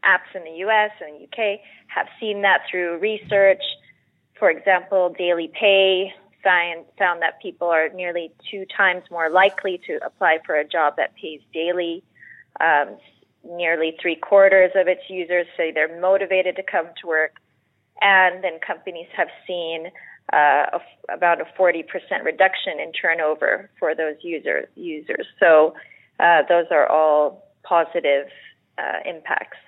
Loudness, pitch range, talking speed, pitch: -20 LUFS, 165-195 Hz, 150 wpm, 175 Hz